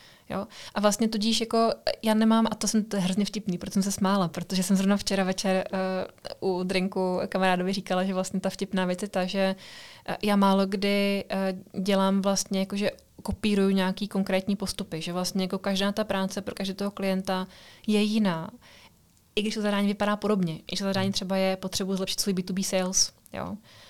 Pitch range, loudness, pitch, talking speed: 190-205 Hz, -27 LUFS, 195 Hz, 190 wpm